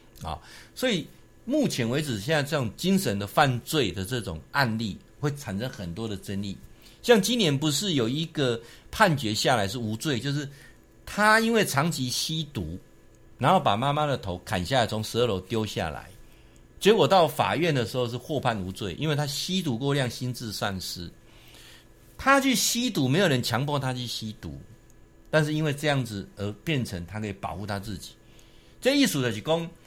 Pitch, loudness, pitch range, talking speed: 125 Hz, -26 LUFS, 105-155 Hz, 265 characters per minute